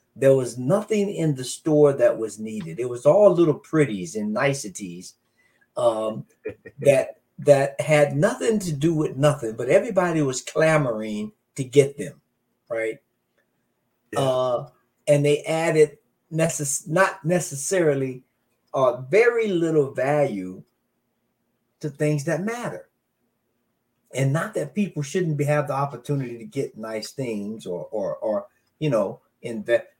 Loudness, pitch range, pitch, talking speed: -23 LUFS, 125-165 Hz, 145 Hz, 135 wpm